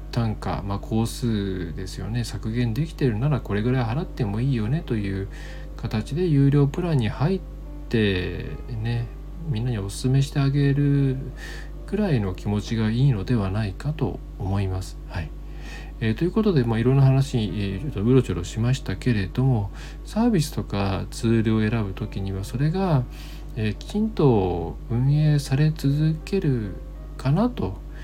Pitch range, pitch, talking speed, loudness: 100-140 Hz, 120 Hz, 310 characters per minute, -24 LUFS